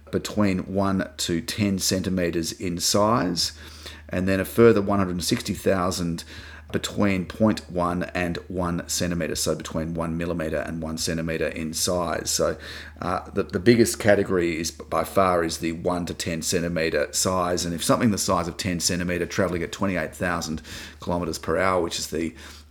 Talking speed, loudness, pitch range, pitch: 155 wpm, -24 LUFS, 80-95 Hz, 90 Hz